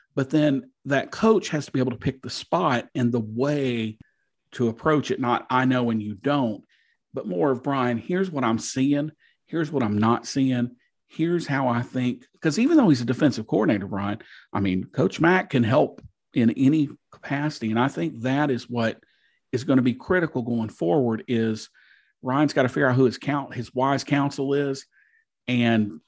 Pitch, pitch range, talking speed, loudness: 130 Hz, 120-145 Hz, 195 wpm, -24 LUFS